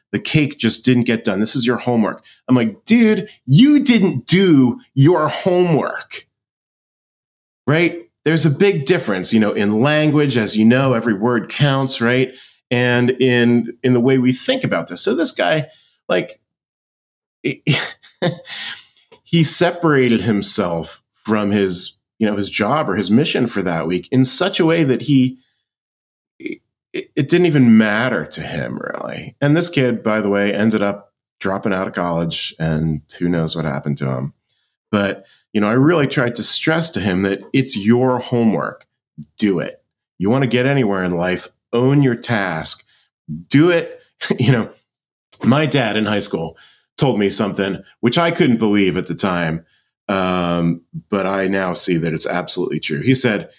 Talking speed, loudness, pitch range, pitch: 170 wpm, -17 LUFS, 100-145 Hz, 120 Hz